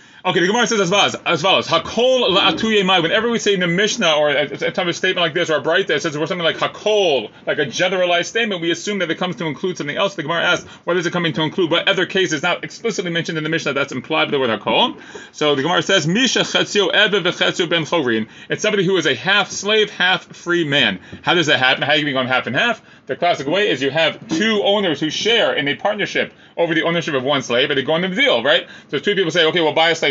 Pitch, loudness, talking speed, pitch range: 175 Hz, -17 LUFS, 265 wpm, 160-200 Hz